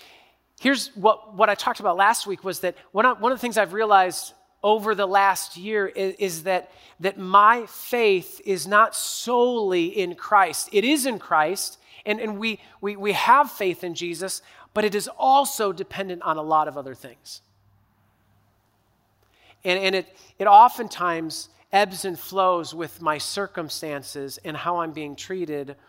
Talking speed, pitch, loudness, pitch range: 165 wpm, 195 Hz, -22 LUFS, 165-220 Hz